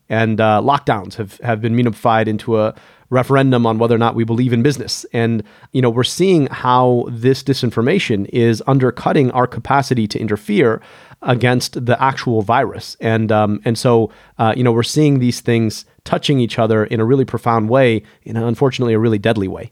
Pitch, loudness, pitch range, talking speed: 120 Hz, -16 LUFS, 110-130 Hz, 190 wpm